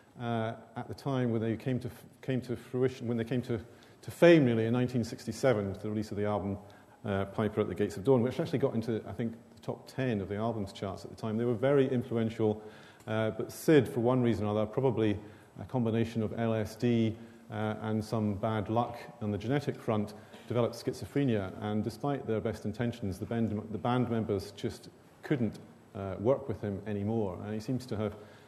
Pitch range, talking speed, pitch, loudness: 105-120 Hz, 210 wpm, 115 Hz, -32 LUFS